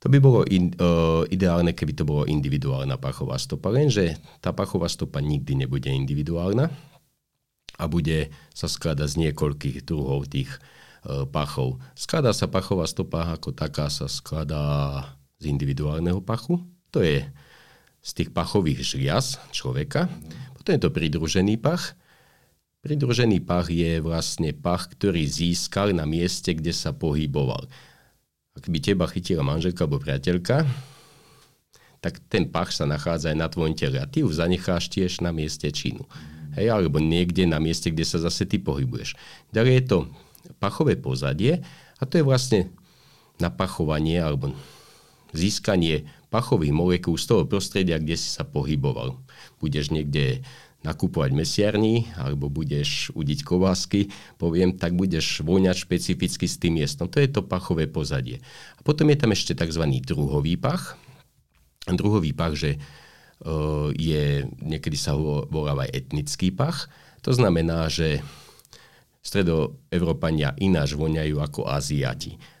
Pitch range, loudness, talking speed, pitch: 75-105 Hz, -24 LUFS, 135 wpm, 85 Hz